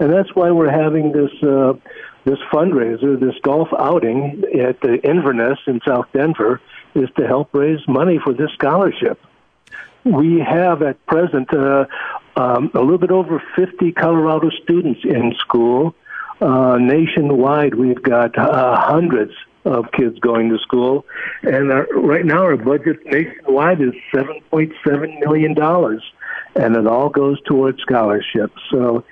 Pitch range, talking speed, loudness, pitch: 135-160 Hz, 150 wpm, -16 LUFS, 145 Hz